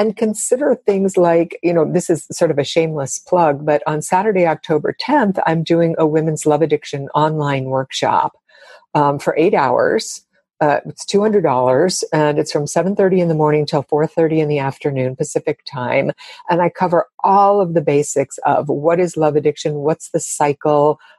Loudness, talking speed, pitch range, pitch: -16 LUFS, 185 wpm, 150-180 Hz, 160 Hz